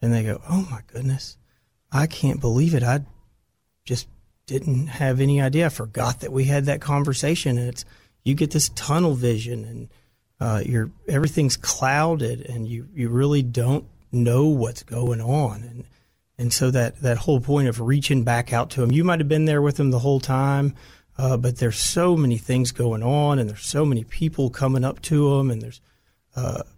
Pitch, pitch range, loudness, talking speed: 130 Hz, 120-145 Hz, -22 LUFS, 195 wpm